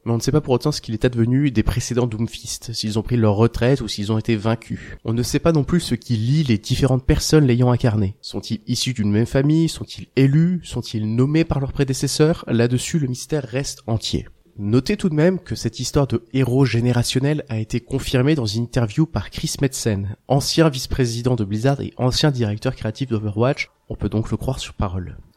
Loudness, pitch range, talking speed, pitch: -20 LUFS, 110-140 Hz, 215 wpm, 125 Hz